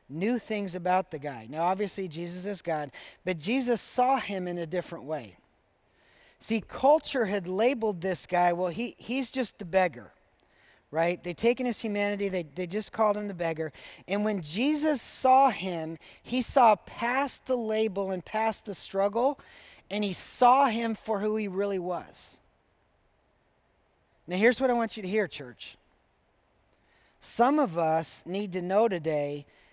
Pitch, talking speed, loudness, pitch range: 195 Hz, 165 wpm, -29 LUFS, 170-230 Hz